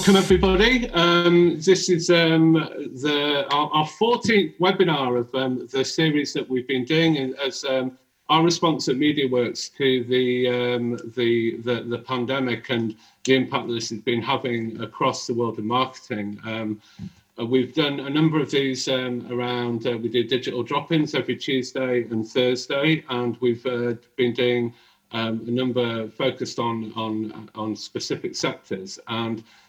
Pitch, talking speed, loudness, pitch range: 125 Hz, 155 wpm, -23 LUFS, 120-150 Hz